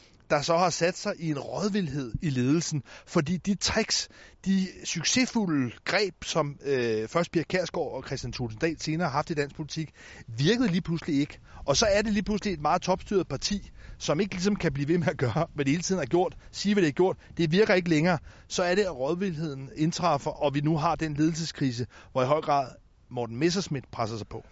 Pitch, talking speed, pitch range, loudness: 160 Hz, 220 wpm, 140-185 Hz, -28 LUFS